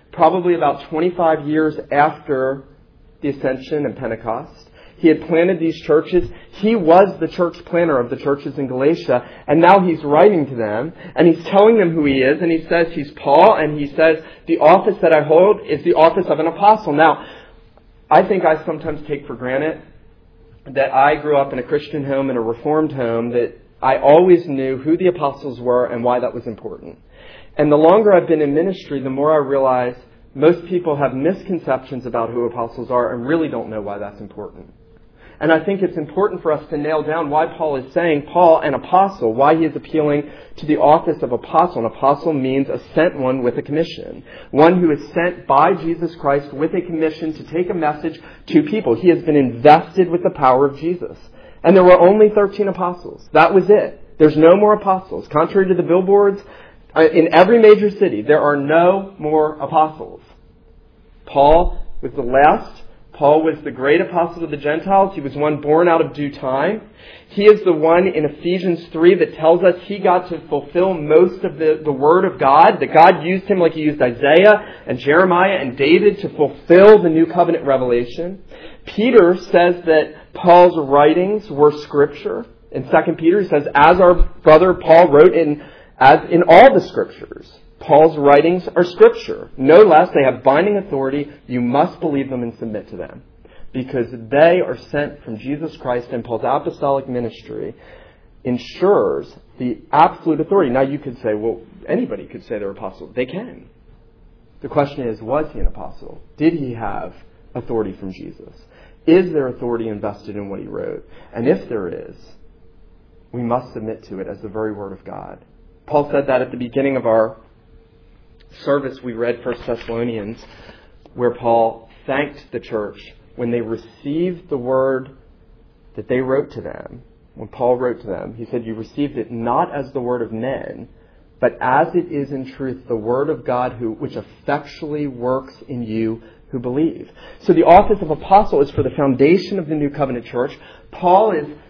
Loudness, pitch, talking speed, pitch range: -15 LUFS, 150 Hz, 185 wpm, 125-170 Hz